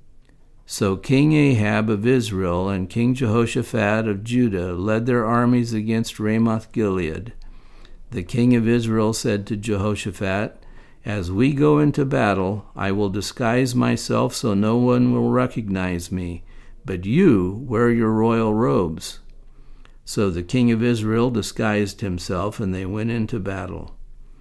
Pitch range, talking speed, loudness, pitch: 100-120 Hz, 140 wpm, -21 LUFS, 110 Hz